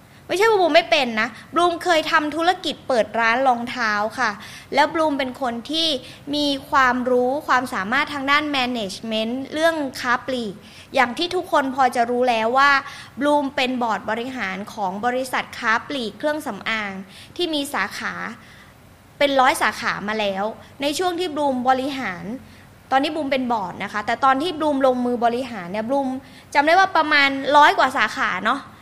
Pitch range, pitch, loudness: 230-295 Hz, 260 Hz, -20 LUFS